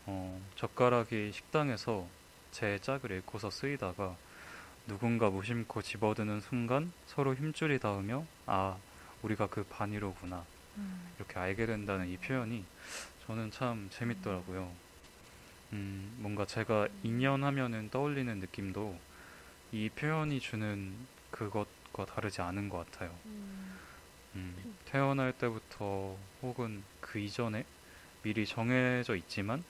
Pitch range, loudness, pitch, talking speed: 95-120 Hz, -37 LUFS, 105 Hz, 255 characters per minute